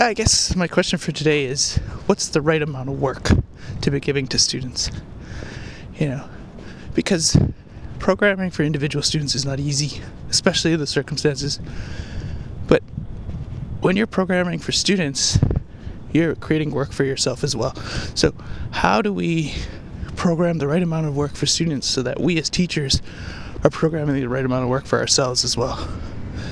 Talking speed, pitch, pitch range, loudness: 165 wpm, 145 Hz, 125-165 Hz, -20 LUFS